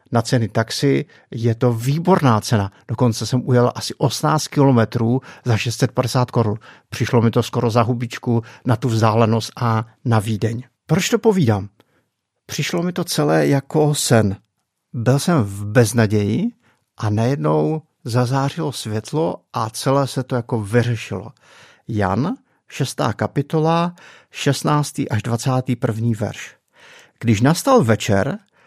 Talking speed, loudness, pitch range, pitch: 130 wpm, -19 LUFS, 115-140 Hz, 120 Hz